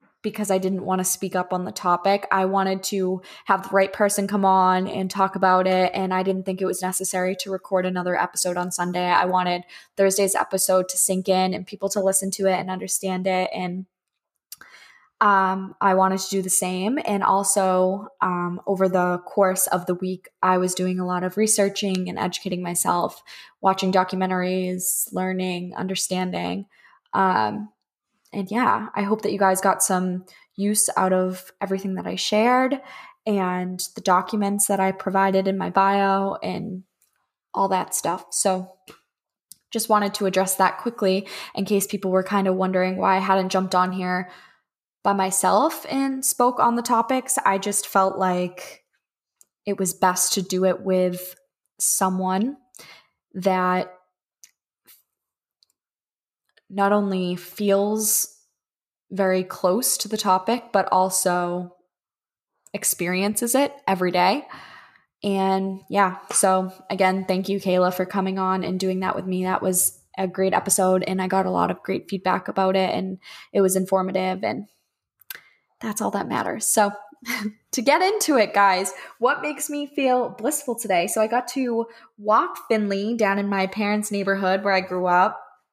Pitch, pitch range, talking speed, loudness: 190 Hz, 185-205 Hz, 165 wpm, -22 LUFS